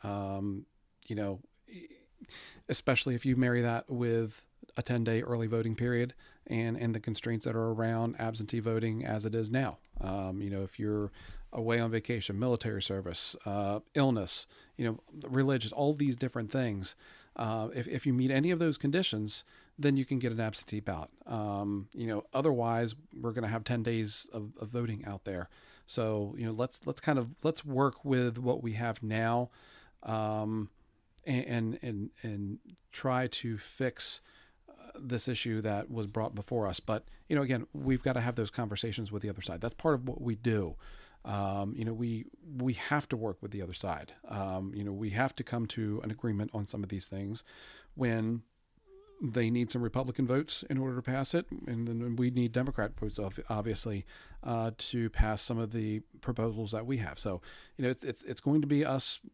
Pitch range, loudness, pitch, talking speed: 105-125 Hz, -34 LUFS, 115 Hz, 190 wpm